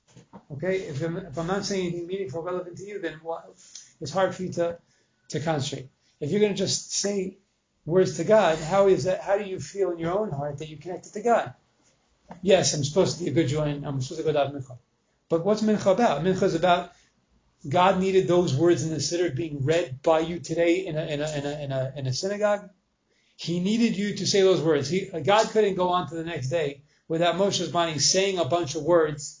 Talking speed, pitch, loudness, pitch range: 230 wpm, 170 Hz, -25 LUFS, 150-190 Hz